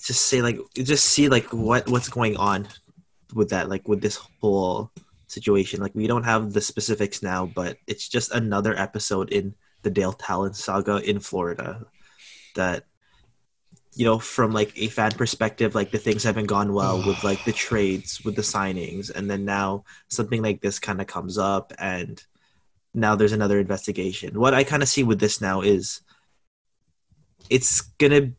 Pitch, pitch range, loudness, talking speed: 105 Hz, 100-115 Hz, -23 LUFS, 175 wpm